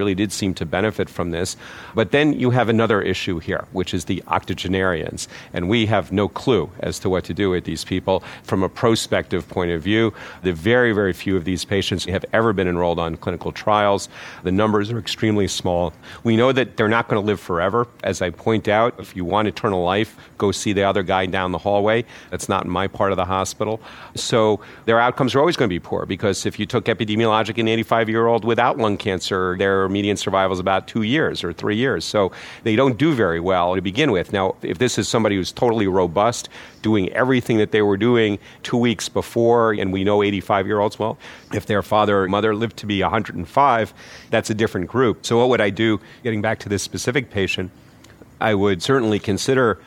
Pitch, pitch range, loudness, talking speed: 105 Hz, 95-115 Hz, -20 LUFS, 220 wpm